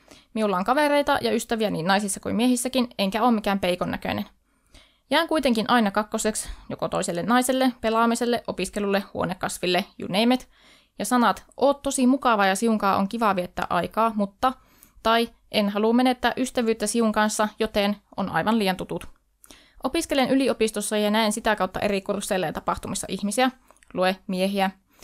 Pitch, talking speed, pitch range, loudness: 220 Hz, 150 wpm, 200-250 Hz, -24 LUFS